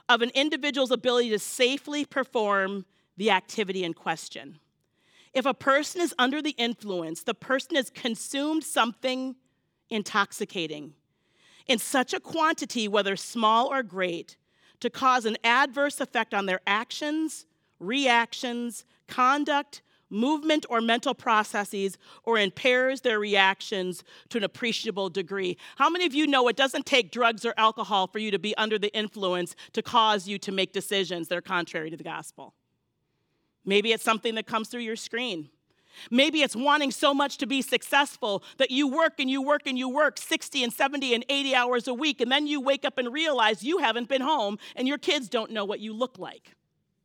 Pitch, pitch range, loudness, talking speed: 235 Hz, 205-275 Hz, -26 LUFS, 175 wpm